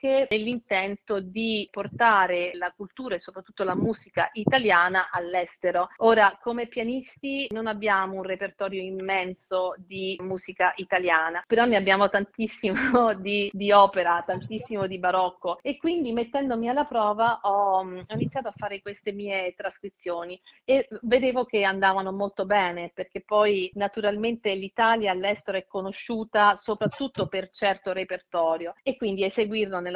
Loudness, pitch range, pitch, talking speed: -25 LUFS, 185-220 Hz, 200 Hz, 130 wpm